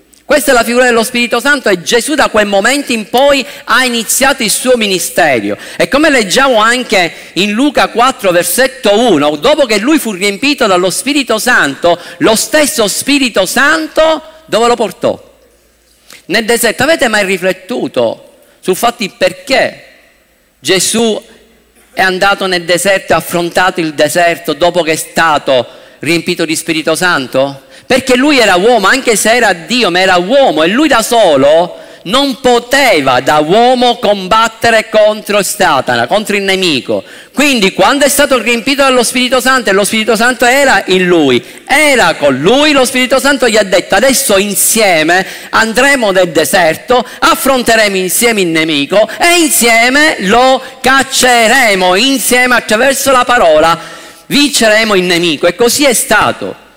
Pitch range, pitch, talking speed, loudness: 185-265 Hz, 230 Hz, 150 wpm, -9 LUFS